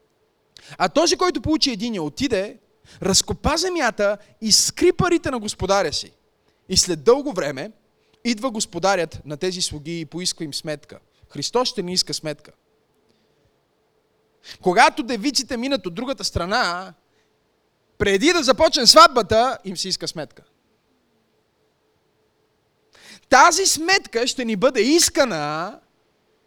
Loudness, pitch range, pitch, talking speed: -19 LUFS, 180-290 Hz, 230 Hz, 120 wpm